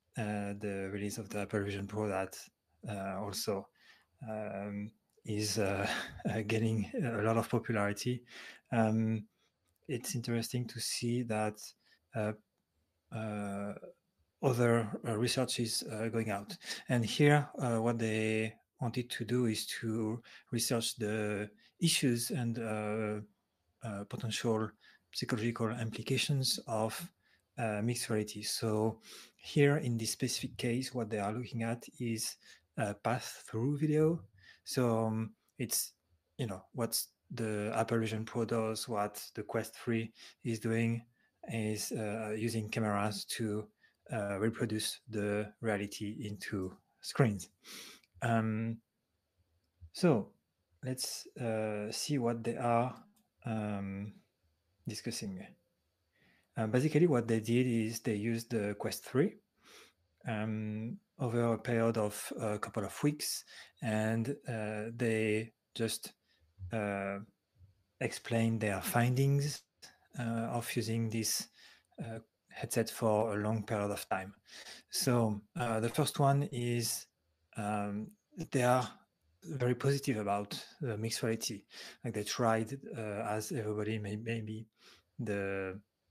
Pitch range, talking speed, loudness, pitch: 105-120 Hz, 125 wpm, -35 LUFS, 110 Hz